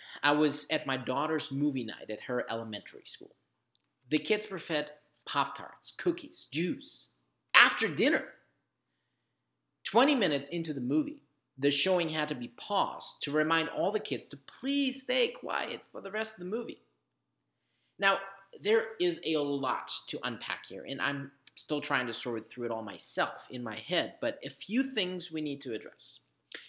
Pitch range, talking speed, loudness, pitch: 130-195 Hz, 170 wpm, -32 LUFS, 150 Hz